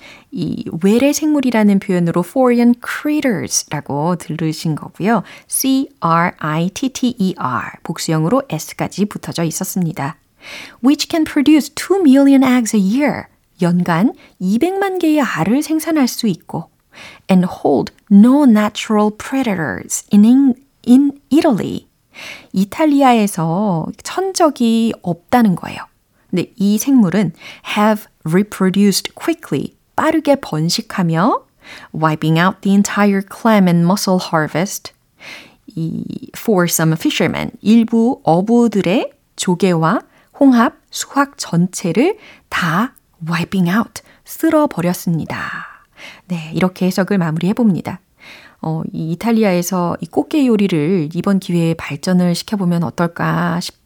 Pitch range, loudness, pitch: 175-265 Hz, -15 LUFS, 205 Hz